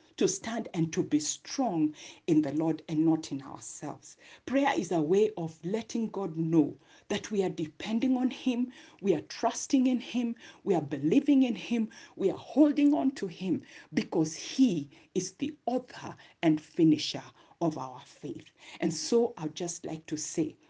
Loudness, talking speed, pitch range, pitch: -30 LUFS, 175 wpm, 160-265 Hz, 200 Hz